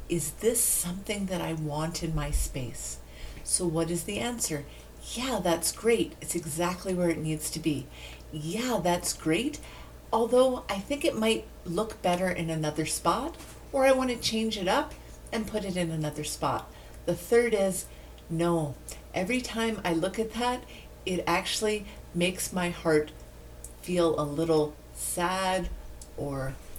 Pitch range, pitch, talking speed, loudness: 155-215 Hz, 175 Hz, 155 wpm, -29 LUFS